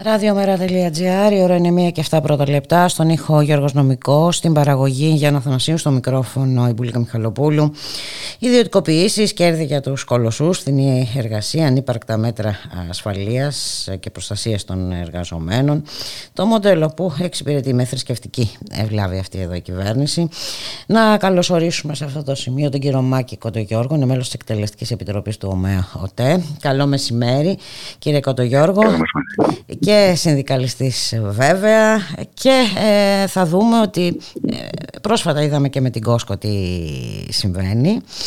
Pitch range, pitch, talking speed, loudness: 115-170 Hz, 140 Hz, 135 wpm, -17 LUFS